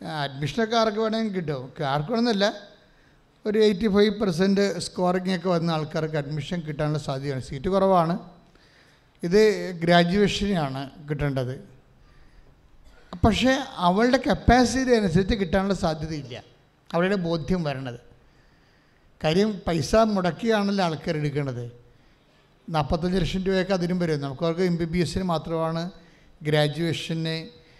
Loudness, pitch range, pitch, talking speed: -24 LUFS, 150-195 Hz, 170 Hz, 105 wpm